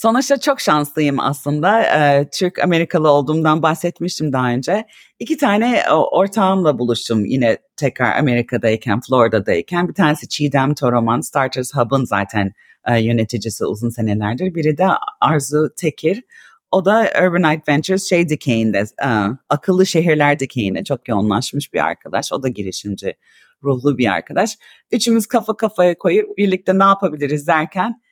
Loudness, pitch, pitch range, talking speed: -17 LUFS, 150 Hz, 125-185 Hz, 125 wpm